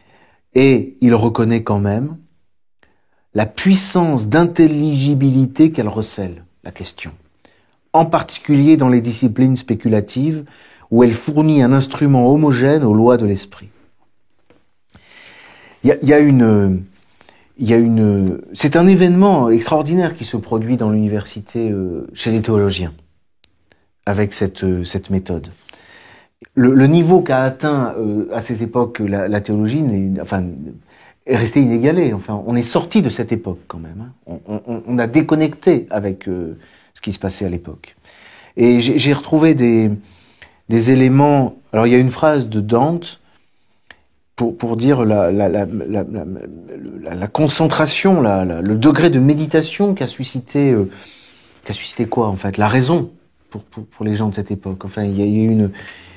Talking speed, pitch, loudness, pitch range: 160 wpm, 115 Hz, -15 LUFS, 100-145 Hz